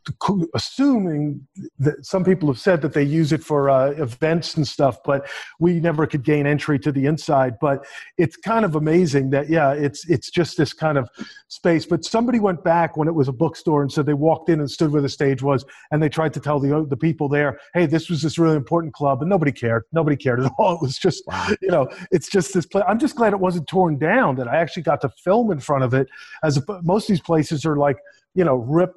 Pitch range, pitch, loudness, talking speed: 140-175 Hz, 155 Hz, -20 LUFS, 240 wpm